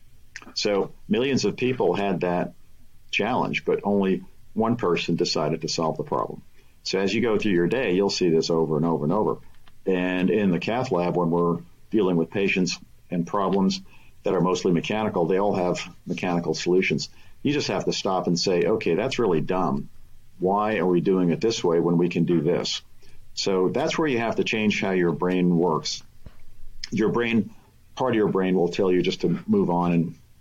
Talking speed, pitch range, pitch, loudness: 195 wpm, 85-100 Hz, 90 Hz, -24 LUFS